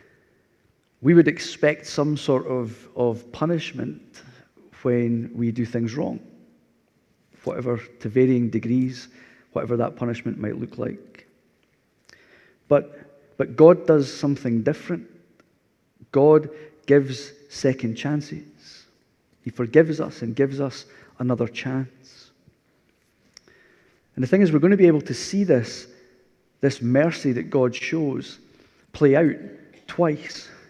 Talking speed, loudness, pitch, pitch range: 115 wpm, -22 LUFS, 135 Hz, 120-150 Hz